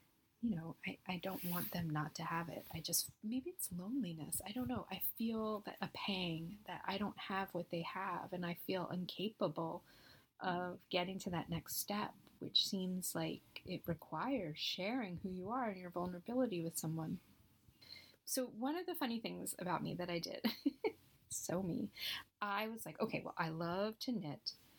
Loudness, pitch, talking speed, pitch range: -42 LUFS, 185 Hz, 185 wpm, 170-220 Hz